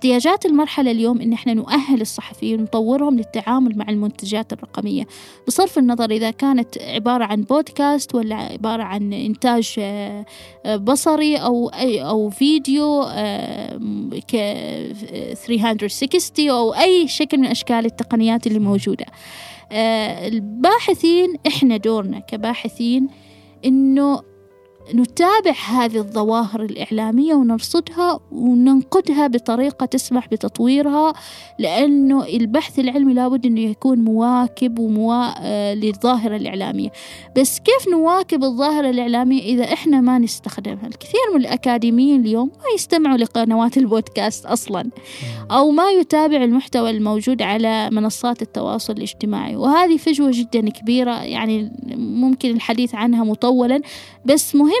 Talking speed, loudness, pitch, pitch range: 105 wpm, -18 LUFS, 245 Hz, 225-275 Hz